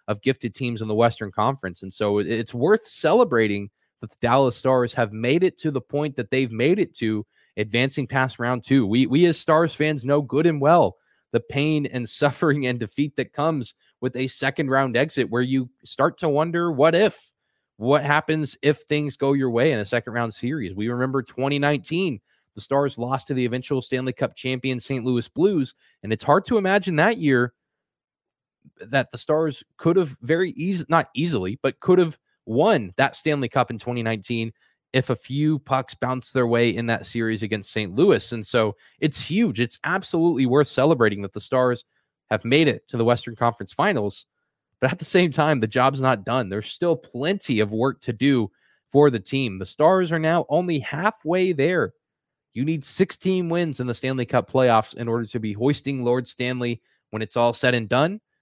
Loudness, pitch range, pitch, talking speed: -22 LUFS, 120-150 Hz, 130 Hz, 195 wpm